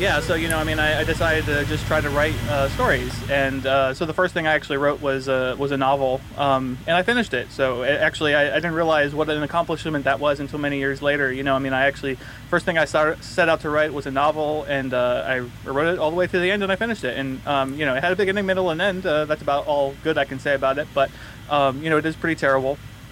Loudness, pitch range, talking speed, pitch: -21 LUFS, 135-155 Hz, 290 wpm, 145 Hz